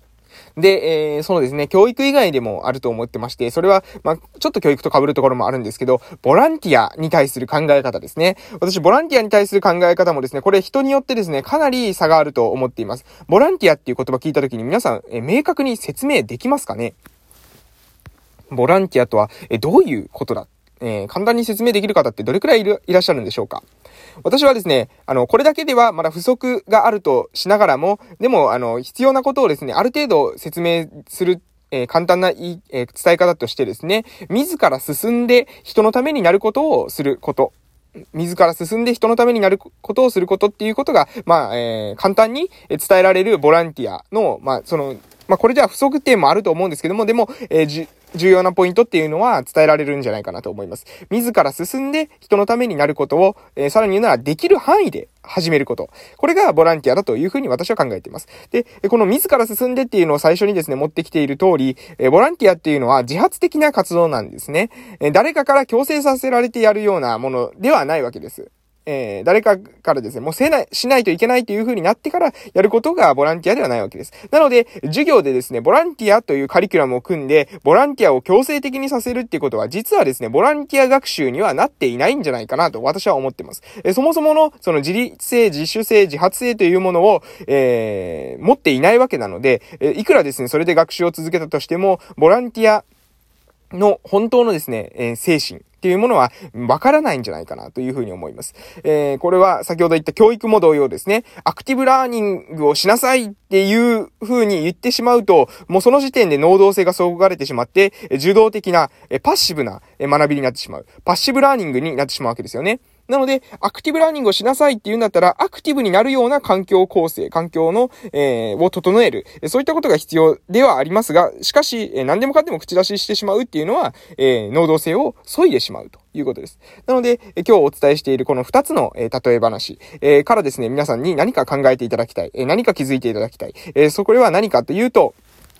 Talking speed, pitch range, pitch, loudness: 460 characters per minute, 150-245 Hz, 190 Hz, -16 LUFS